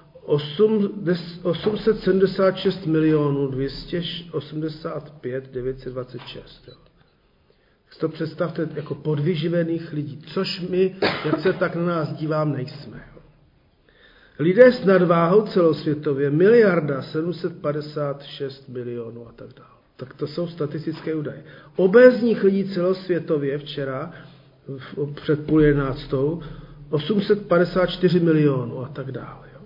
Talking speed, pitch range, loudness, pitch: 95 wpm, 145-175 Hz, -21 LUFS, 155 Hz